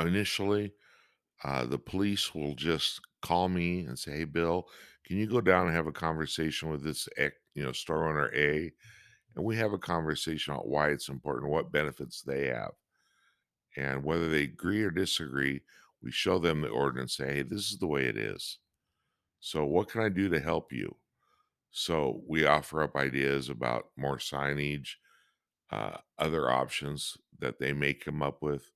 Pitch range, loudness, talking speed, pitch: 70-90 Hz, -32 LUFS, 175 wpm, 75 Hz